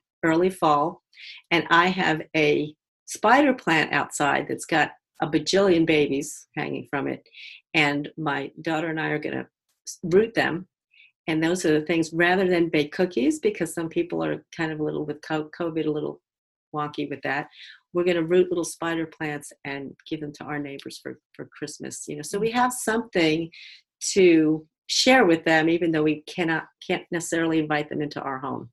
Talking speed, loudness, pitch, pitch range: 185 wpm, -24 LUFS, 160 Hz, 150-175 Hz